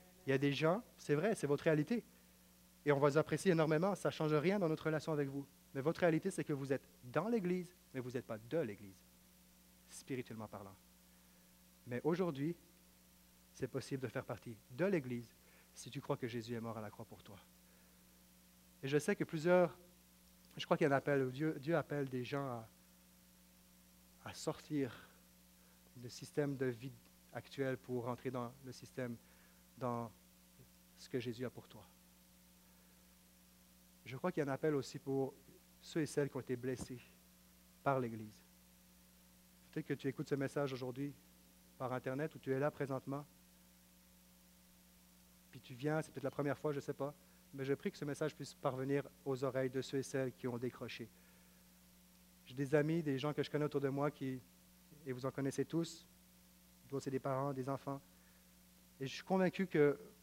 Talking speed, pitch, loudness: 185 wpm, 130 Hz, -40 LUFS